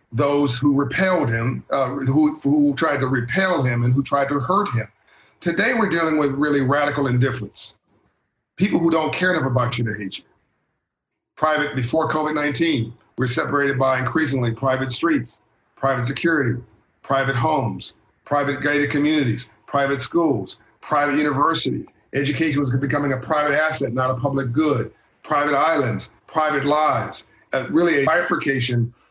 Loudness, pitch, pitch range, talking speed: -20 LUFS, 140 Hz, 130-150 Hz, 150 wpm